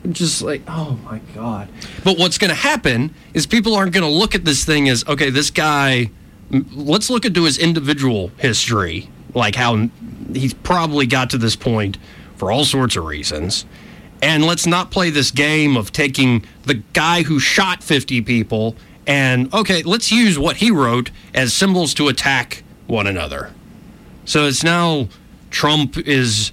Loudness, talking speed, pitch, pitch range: -16 LUFS, 165 wpm, 140 Hz, 115-165 Hz